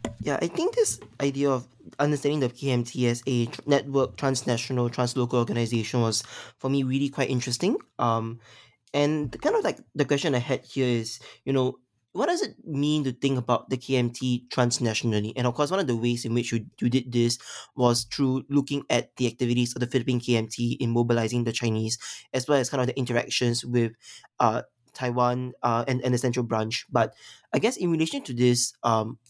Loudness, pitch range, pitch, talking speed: -26 LUFS, 120-135 Hz, 125 Hz, 195 wpm